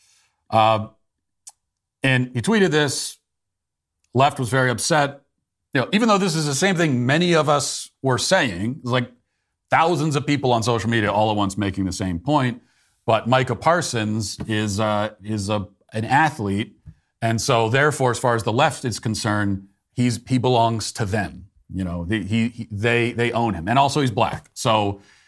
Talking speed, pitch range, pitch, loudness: 180 wpm, 105-135 Hz, 115 Hz, -21 LUFS